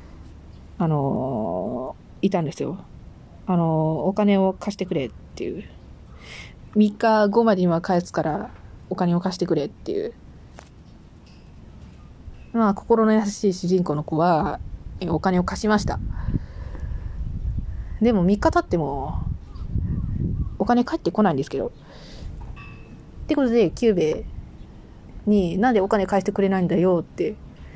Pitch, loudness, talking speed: 180 Hz, -23 LUFS, 240 characters per minute